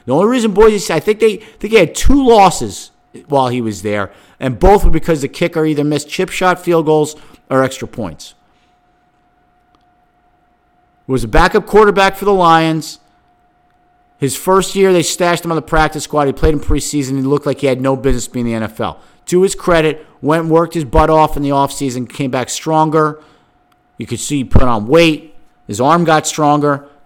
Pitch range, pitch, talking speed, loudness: 135-170 Hz, 155 Hz, 200 wpm, -13 LUFS